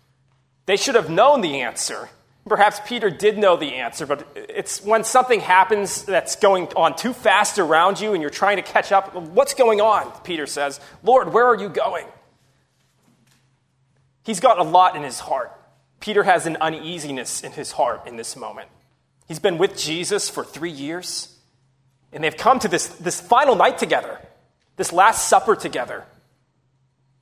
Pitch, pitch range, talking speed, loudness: 180 Hz, 135-210 Hz, 170 wpm, -19 LUFS